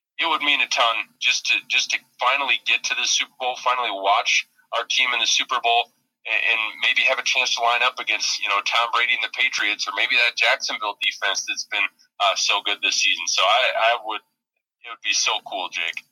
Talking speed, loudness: 225 wpm, -20 LUFS